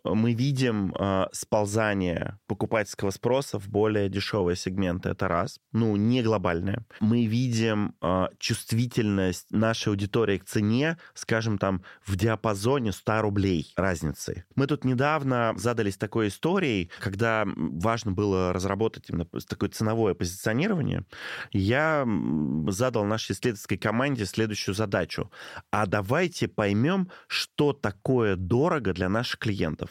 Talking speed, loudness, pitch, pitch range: 120 wpm, -27 LUFS, 110 Hz, 95-115 Hz